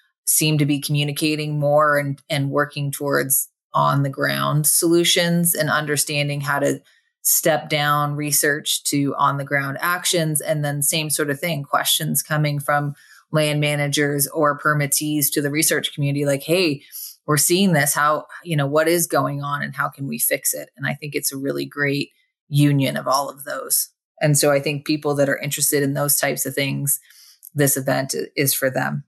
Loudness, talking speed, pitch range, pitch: -19 LUFS, 185 wpm, 140-155 Hz, 145 Hz